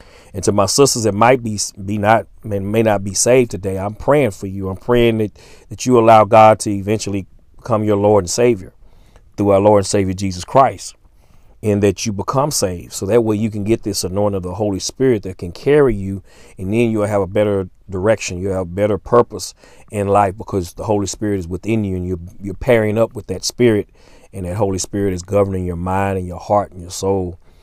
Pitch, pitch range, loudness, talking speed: 100 Hz, 95-110 Hz, -16 LUFS, 225 wpm